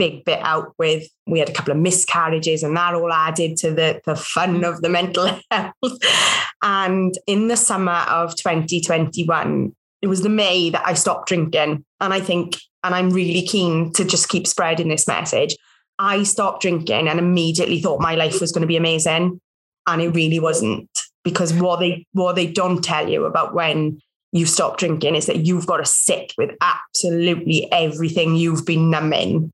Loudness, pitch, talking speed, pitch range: -18 LUFS, 175 Hz, 185 wpm, 165-185 Hz